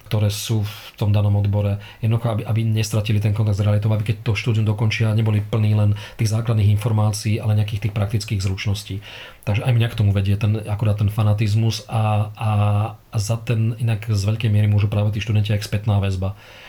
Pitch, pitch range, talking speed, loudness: 105 Hz, 105-110 Hz, 200 wpm, -21 LUFS